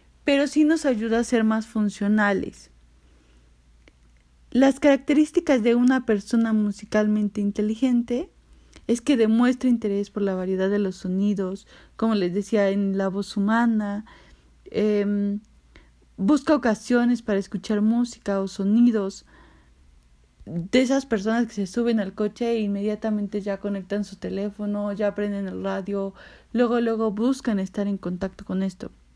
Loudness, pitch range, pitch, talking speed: -23 LUFS, 195-235 Hz, 210 Hz, 135 wpm